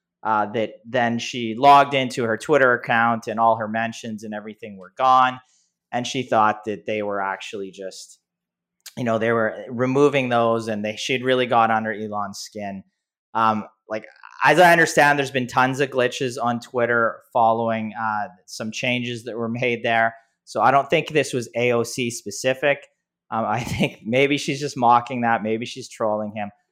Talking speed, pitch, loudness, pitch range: 190 wpm, 115 Hz, -21 LUFS, 110-130 Hz